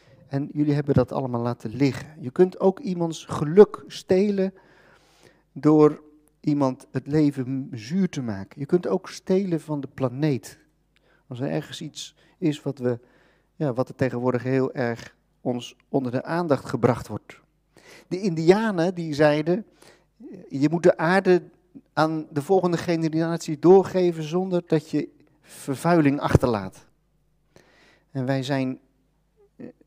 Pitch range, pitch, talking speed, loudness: 135-170 Hz, 150 Hz, 135 wpm, -23 LUFS